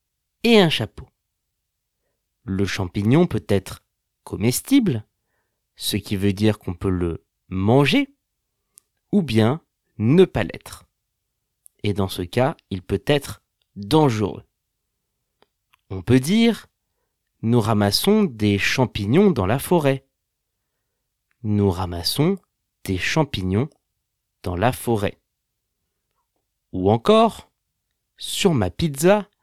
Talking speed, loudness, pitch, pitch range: 105 wpm, -20 LUFS, 110 Hz, 100-145 Hz